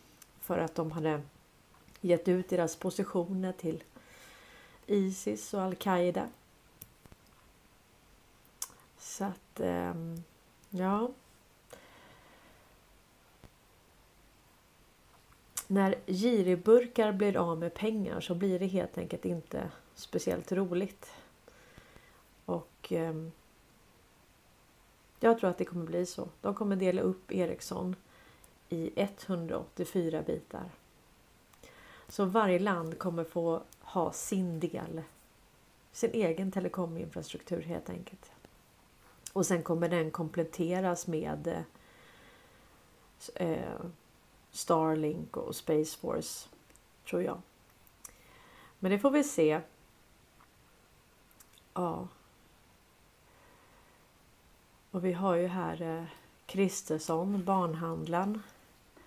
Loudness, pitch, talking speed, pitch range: -33 LUFS, 175 Hz, 85 wpm, 165-190 Hz